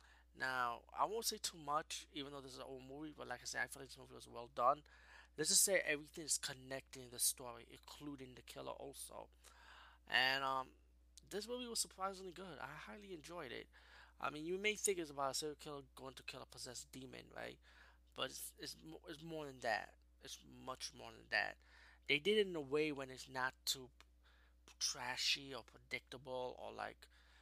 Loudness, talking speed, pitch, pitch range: -42 LUFS, 205 wpm, 135 Hz, 125-160 Hz